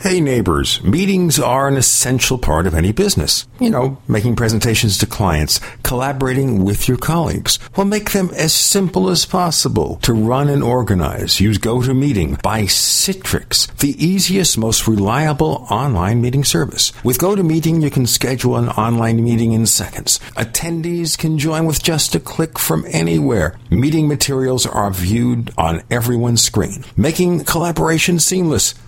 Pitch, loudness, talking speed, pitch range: 130 Hz, -15 LUFS, 150 wpm, 110-160 Hz